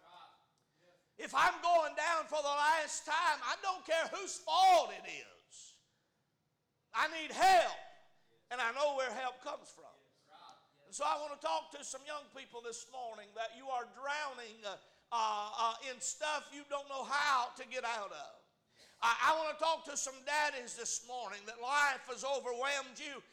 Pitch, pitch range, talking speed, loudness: 280 Hz, 245-305 Hz, 175 wpm, -35 LUFS